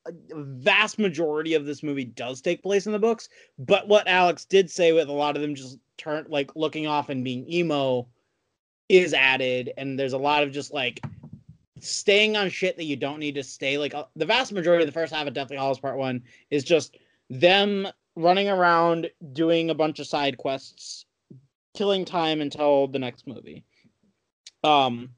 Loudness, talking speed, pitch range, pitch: -24 LUFS, 190 wpm, 135-175 Hz, 150 Hz